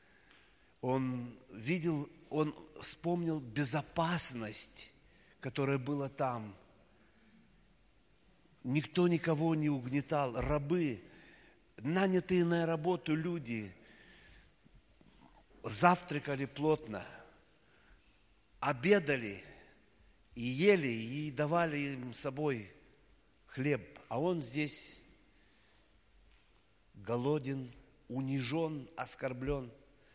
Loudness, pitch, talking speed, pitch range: -35 LUFS, 140 Hz, 70 wpm, 115-155 Hz